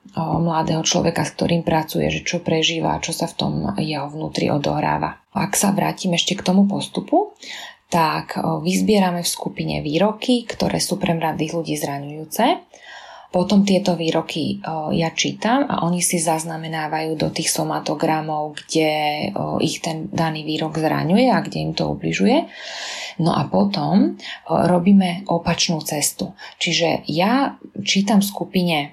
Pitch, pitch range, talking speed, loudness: 170 Hz, 160-190 Hz, 140 wpm, -20 LUFS